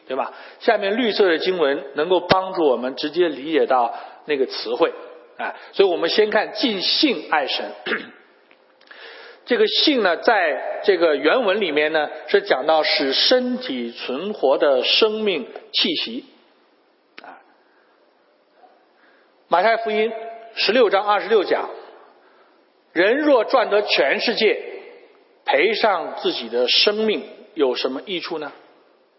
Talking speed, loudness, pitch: 190 characters per minute, -19 LUFS, 250 Hz